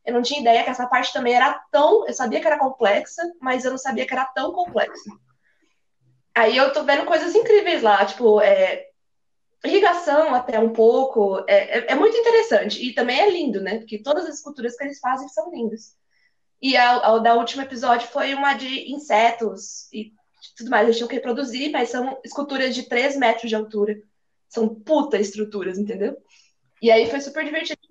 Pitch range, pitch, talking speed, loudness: 225-290 Hz, 255 Hz, 190 wpm, -20 LUFS